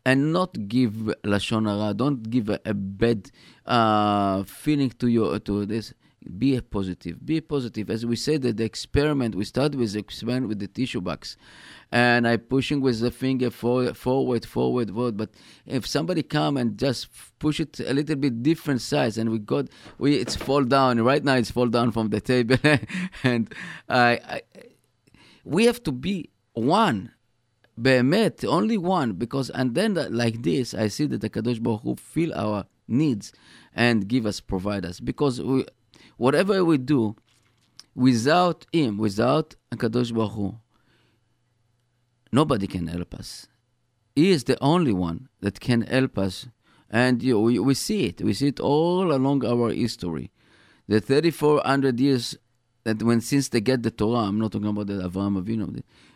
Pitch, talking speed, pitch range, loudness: 120 Hz, 175 wpm, 110-135 Hz, -24 LUFS